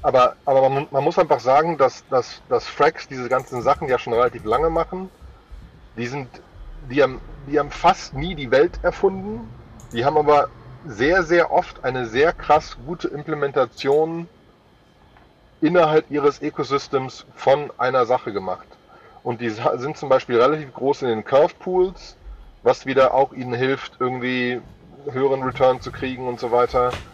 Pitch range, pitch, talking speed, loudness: 125-155 Hz, 135 Hz, 160 wpm, -20 LUFS